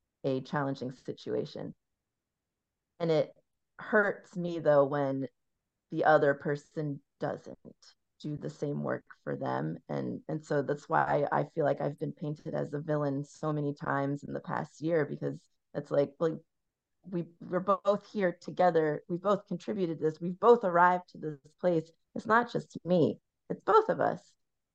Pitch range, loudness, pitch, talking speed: 140-175 Hz, -31 LUFS, 155 Hz, 160 wpm